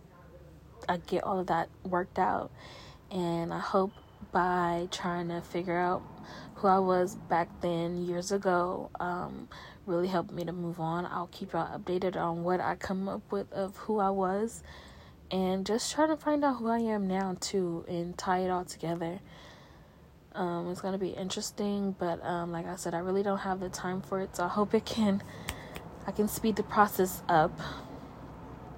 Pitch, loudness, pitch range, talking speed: 180 Hz, -32 LUFS, 175-195 Hz, 185 wpm